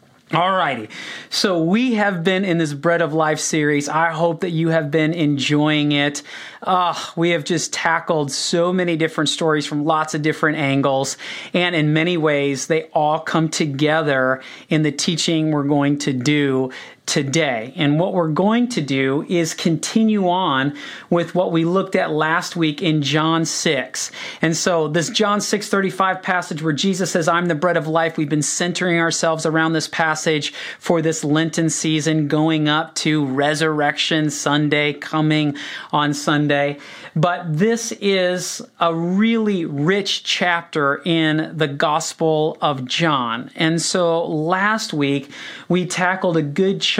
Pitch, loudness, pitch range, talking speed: 160 Hz, -19 LUFS, 150-175 Hz, 155 wpm